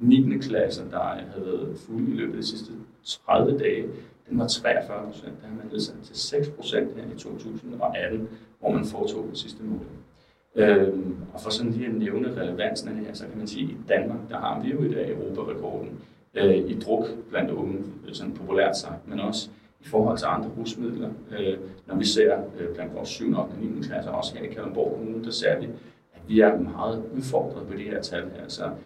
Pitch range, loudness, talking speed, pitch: 95-115 Hz, -27 LUFS, 210 wpm, 110 Hz